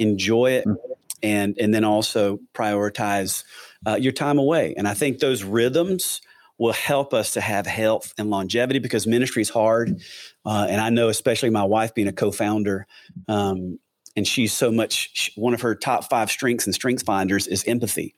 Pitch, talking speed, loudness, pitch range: 110 Hz, 180 wpm, -22 LUFS, 100-120 Hz